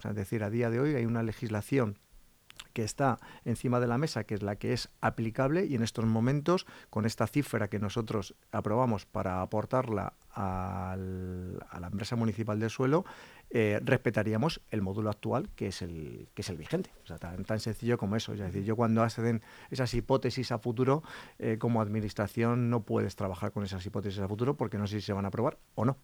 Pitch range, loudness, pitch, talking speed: 105-120 Hz, -32 LUFS, 110 Hz, 210 wpm